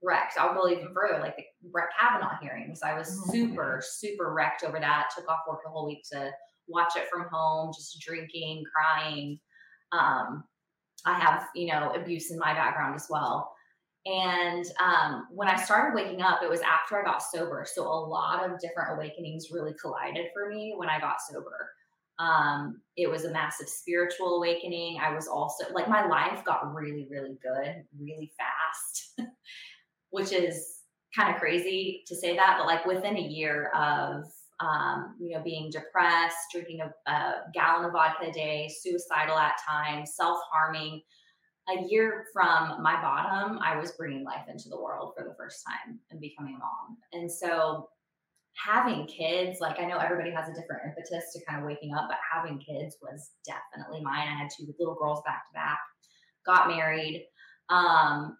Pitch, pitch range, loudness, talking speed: 165 Hz, 155-180 Hz, -29 LUFS, 180 wpm